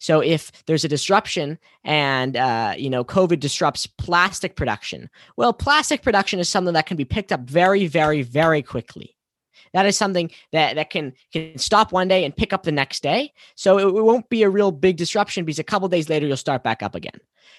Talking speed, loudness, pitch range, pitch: 215 wpm, -20 LUFS, 150-195 Hz, 175 Hz